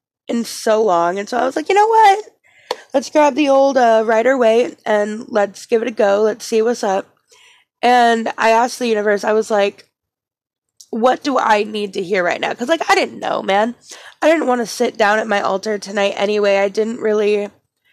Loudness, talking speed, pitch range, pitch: -16 LUFS, 215 wpm, 205-245 Hz, 220 Hz